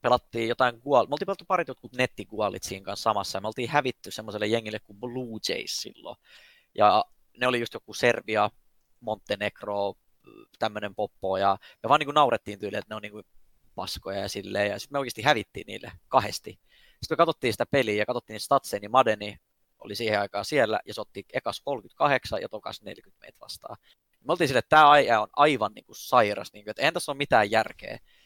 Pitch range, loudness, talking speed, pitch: 105-125 Hz, -26 LUFS, 200 wpm, 110 Hz